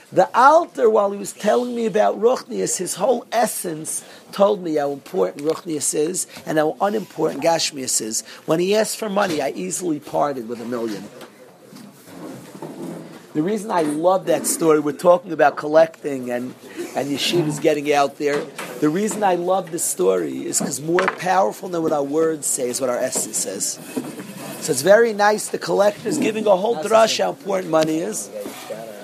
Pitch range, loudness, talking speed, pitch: 150-205 Hz, -20 LUFS, 175 wpm, 165 Hz